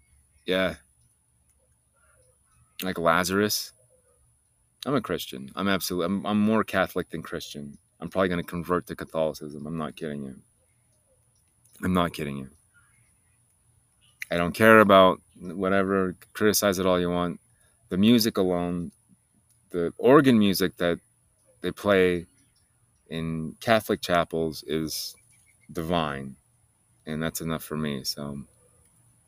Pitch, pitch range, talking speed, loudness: 90 Hz, 80-105 Hz, 120 wpm, -25 LUFS